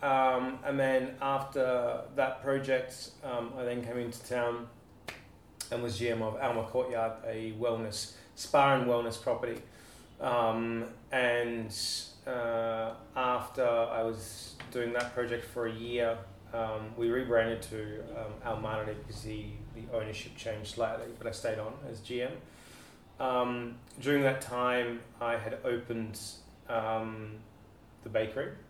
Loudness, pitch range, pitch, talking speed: -33 LUFS, 110-125 Hz, 115 Hz, 135 wpm